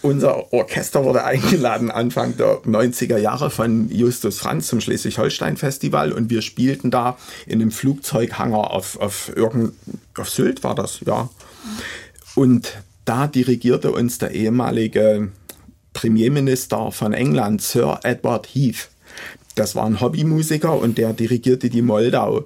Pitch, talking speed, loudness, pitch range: 120 Hz, 130 wpm, -19 LUFS, 110-130 Hz